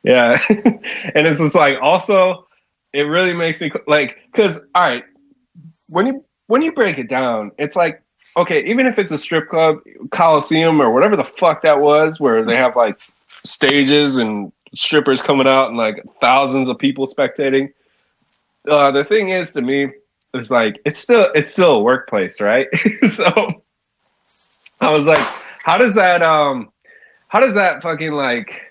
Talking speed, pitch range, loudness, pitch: 165 wpm, 140-185 Hz, -15 LUFS, 155 Hz